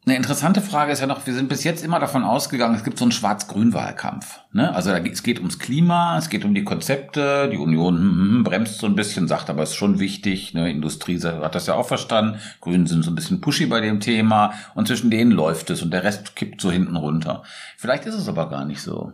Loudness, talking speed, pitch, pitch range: -21 LUFS, 245 wpm, 115 Hz, 90-145 Hz